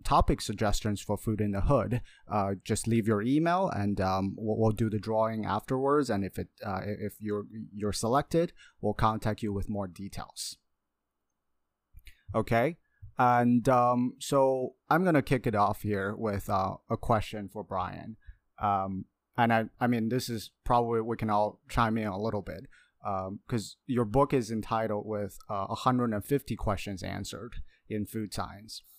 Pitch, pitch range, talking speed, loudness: 110 Hz, 100-120 Hz, 170 wpm, -30 LUFS